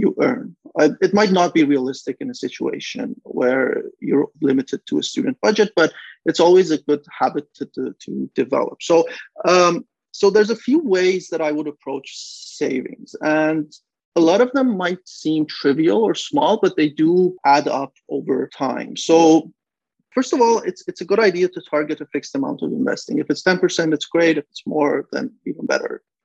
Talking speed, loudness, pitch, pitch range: 190 wpm, -19 LUFS, 175 Hz, 155-245 Hz